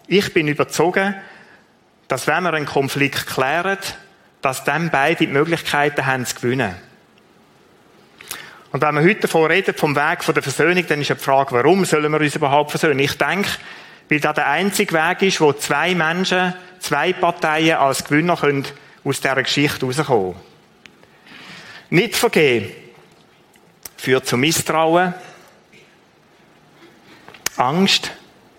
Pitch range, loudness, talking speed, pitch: 145-180 Hz, -18 LUFS, 135 wpm, 155 Hz